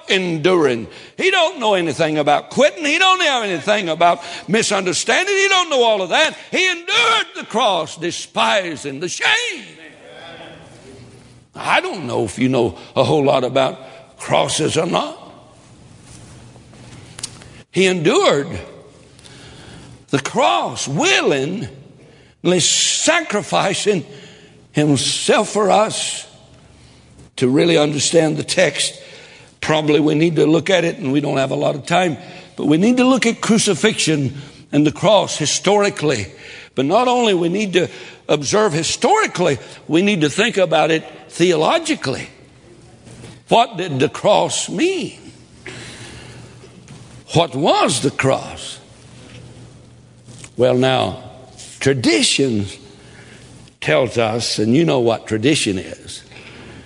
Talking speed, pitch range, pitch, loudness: 120 wpm, 130-200 Hz, 155 Hz, -16 LUFS